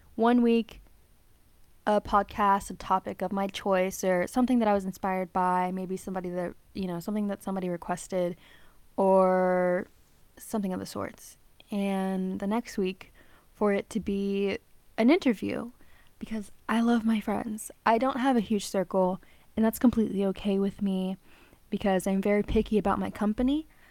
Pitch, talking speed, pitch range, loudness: 200 Hz, 160 wpm, 190-220 Hz, -28 LUFS